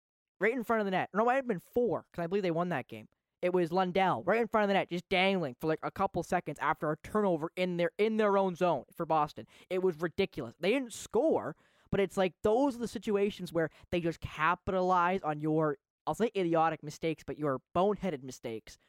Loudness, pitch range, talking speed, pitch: -32 LUFS, 155-195 Hz, 230 wpm, 180 Hz